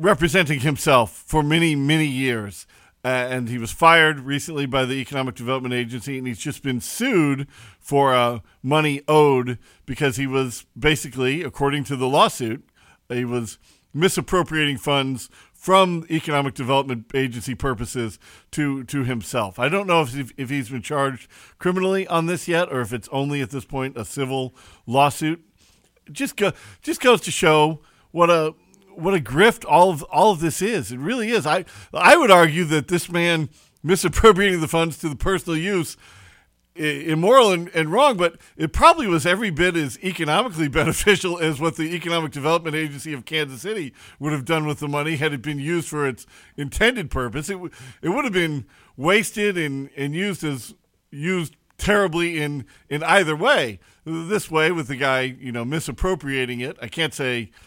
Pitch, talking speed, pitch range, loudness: 150 Hz, 175 wpm, 130-170 Hz, -21 LUFS